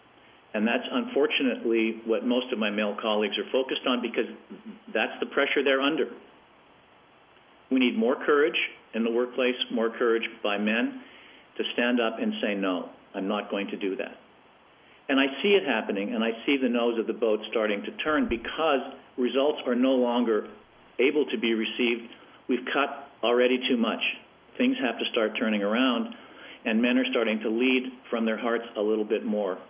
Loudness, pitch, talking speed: -26 LUFS, 125 Hz, 180 wpm